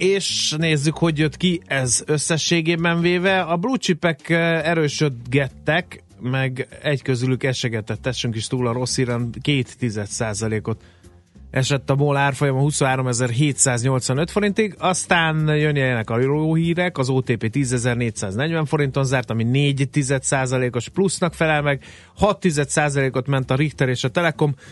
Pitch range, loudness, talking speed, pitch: 125-160 Hz, -20 LUFS, 130 wpm, 140 Hz